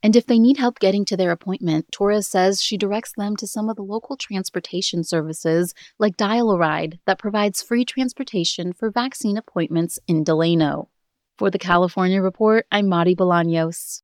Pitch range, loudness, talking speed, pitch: 175-220 Hz, -20 LUFS, 165 wpm, 195 Hz